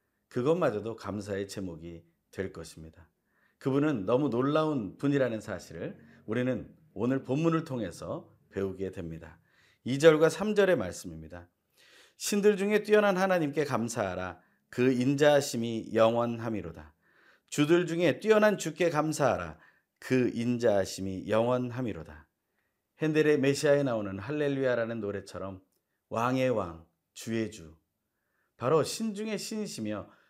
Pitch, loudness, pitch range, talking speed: 120 Hz, -29 LUFS, 95-150 Hz, 285 characters per minute